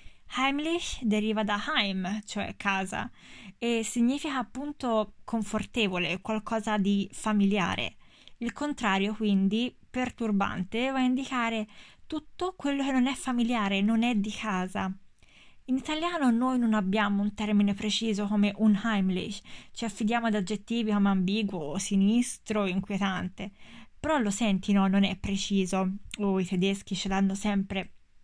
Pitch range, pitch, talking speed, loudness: 195-235 Hz, 210 Hz, 135 wpm, -29 LUFS